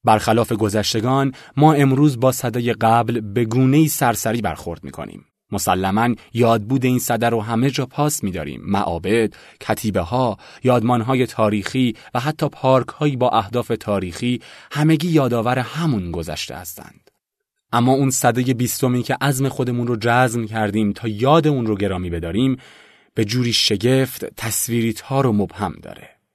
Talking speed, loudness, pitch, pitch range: 150 wpm, -19 LUFS, 120 Hz, 110-130 Hz